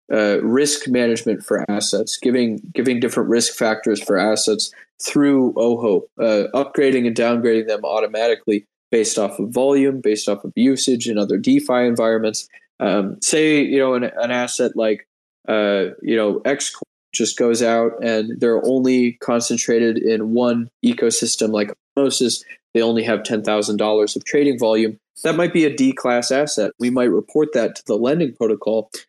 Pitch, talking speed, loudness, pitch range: 120 Hz, 165 wpm, -18 LUFS, 110-130 Hz